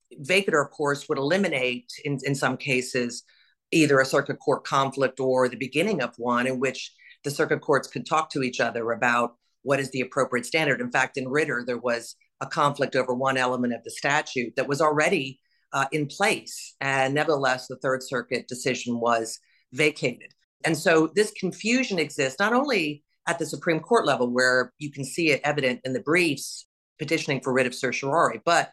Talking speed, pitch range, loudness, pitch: 190 wpm, 125-150 Hz, -25 LUFS, 135 Hz